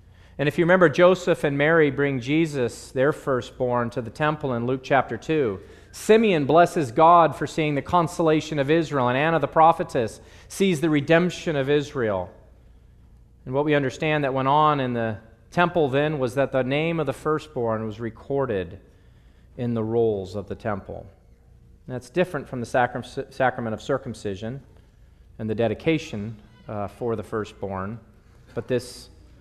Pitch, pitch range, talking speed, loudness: 130 Hz, 110-155 Hz, 165 wpm, -23 LUFS